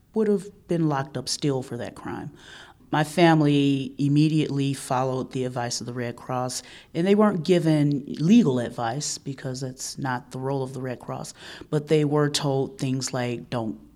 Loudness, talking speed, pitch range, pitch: -24 LUFS, 175 wpm, 125-150 Hz, 135 Hz